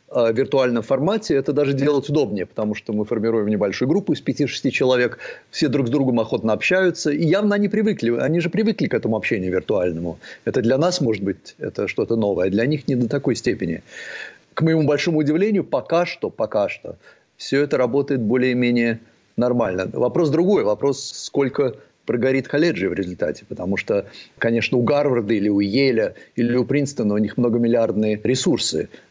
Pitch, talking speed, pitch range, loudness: 125 Hz, 170 wpm, 115-150 Hz, -20 LUFS